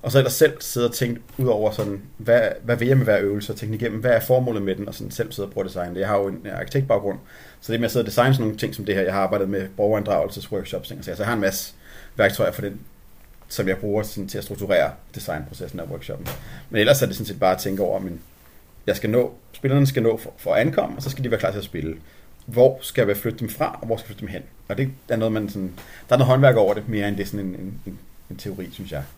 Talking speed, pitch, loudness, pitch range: 290 wpm, 105 Hz, -22 LUFS, 95-120 Hz